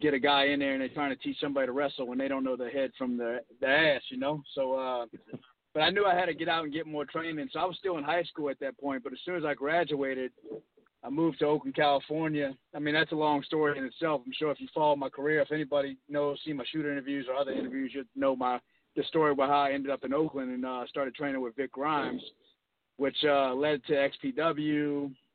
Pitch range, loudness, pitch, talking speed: 135-155 Hz, -31 LUFS, 145 Hz, 260 wpm